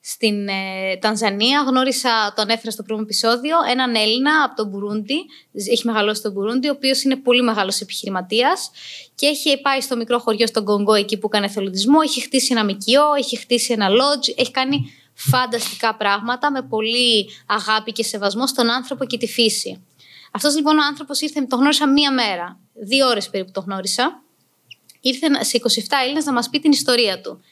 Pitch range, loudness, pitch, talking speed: 215-270 Hz, -18 LUFS, 235 Hz, 180 wpm